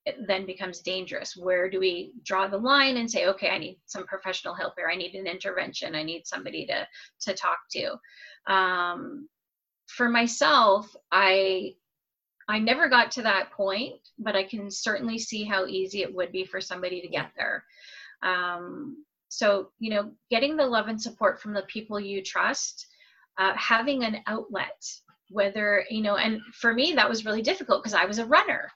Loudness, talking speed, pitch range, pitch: -26 LUFS, 185 wpm, 190-235 Hz, 205 Hz